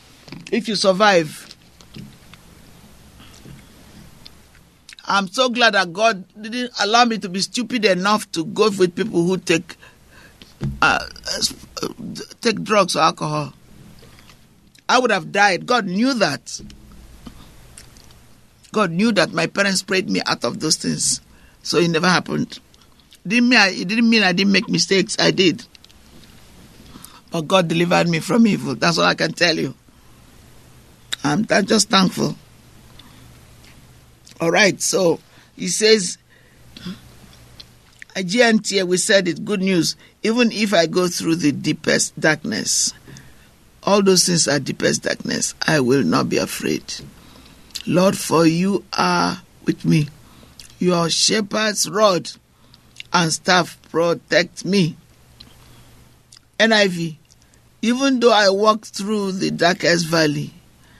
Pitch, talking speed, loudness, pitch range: 190 Hz, 125 wpm, -18 LUFS, 165-215 Hz